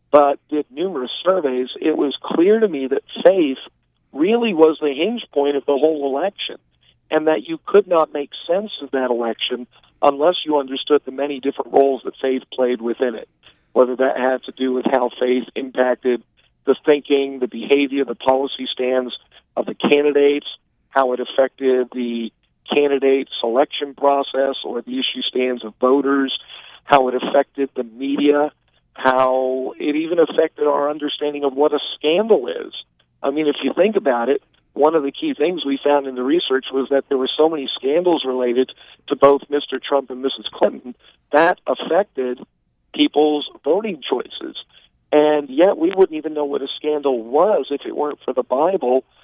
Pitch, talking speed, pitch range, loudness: 140 Hz, 175 wpm, 130-145 Hz, -19 LUFS